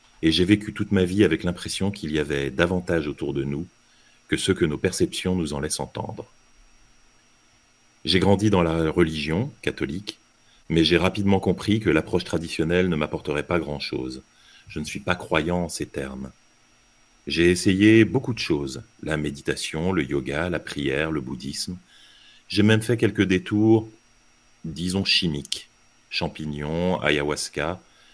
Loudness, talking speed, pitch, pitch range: -23 LUFS, 150 wpm, 85 Hz, 70-100 Hz